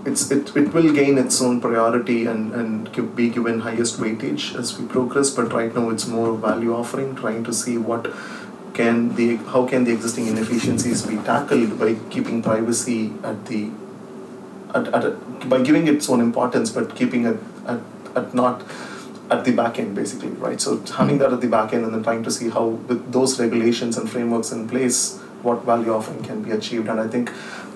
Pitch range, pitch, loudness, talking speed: 115-125 Hz, 120 Hz, -21 LUFS, 195 wpm